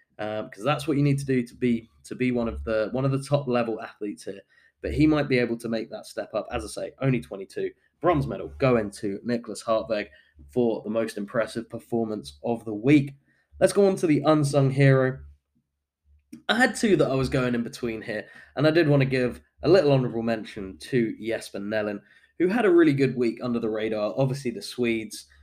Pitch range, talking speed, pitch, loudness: 110-140 Hz, 220 wpm, 120 Hz, -25 LUFS